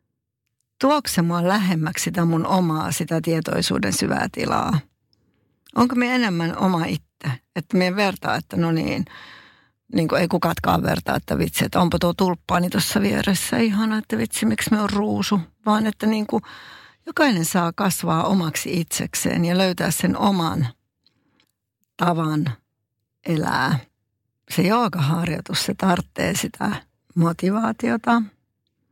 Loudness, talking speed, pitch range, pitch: -21 LUFS, 130 wpm, 155-205 Hz, 175 Hz